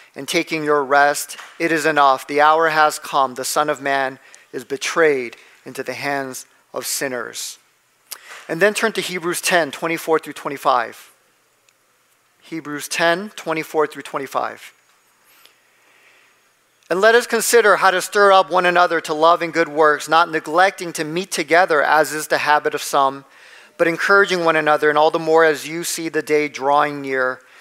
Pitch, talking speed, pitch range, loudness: 160 Hz, 165 wpm, 145-175 Hz, -17 LUFS